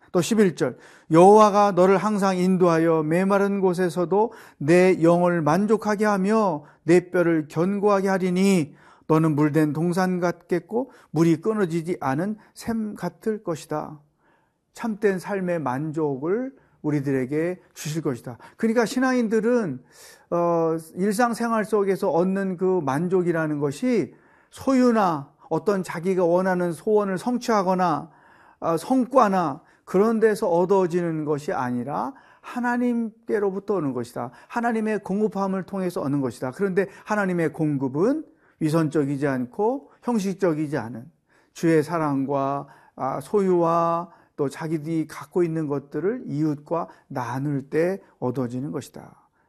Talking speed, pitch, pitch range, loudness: 275 characters per minute, 180 Hz, 155-205 Hz, -23 LUFS